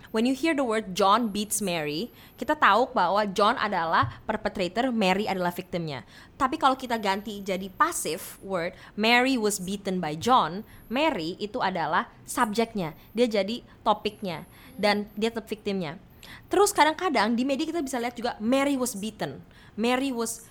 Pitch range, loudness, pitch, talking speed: 195-250 Hz, -26 LUFS, 215 Hz, 155 wpm